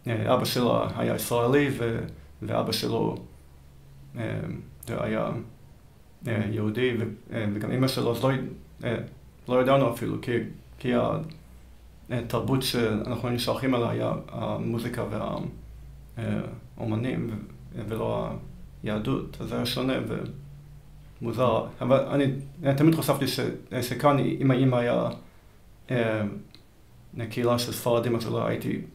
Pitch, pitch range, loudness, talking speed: 120 Hz, 105-130 Hz, -27 LUFS, 95 wpm